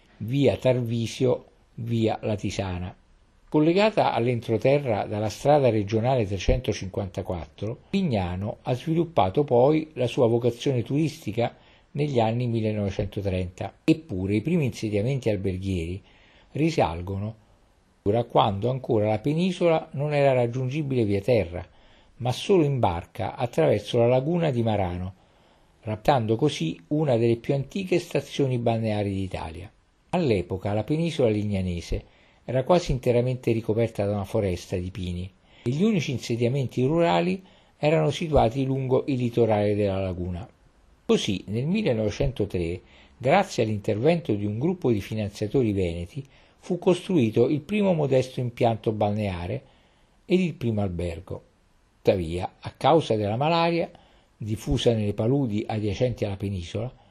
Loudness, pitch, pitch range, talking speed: -25 LUFS, 115 Hz, 100-140 Hz, 120 wpm